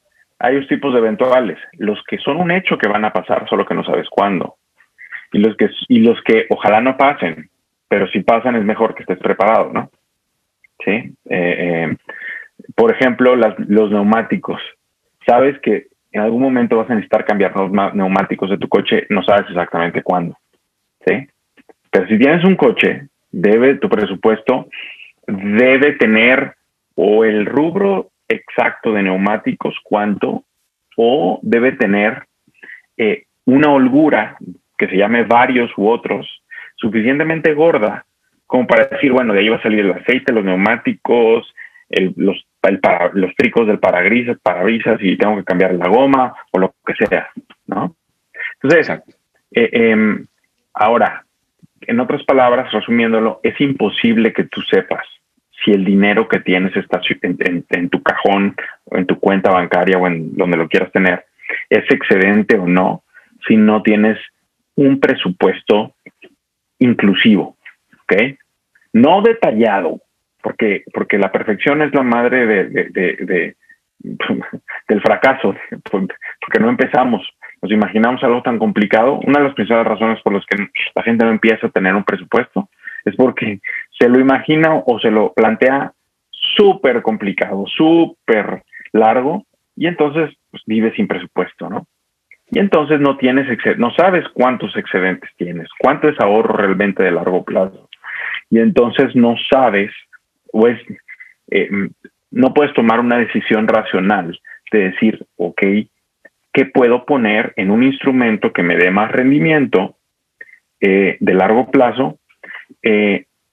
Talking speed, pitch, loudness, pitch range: 150 wpm, 115 Hz, -14 LUFS, 105-140 Hz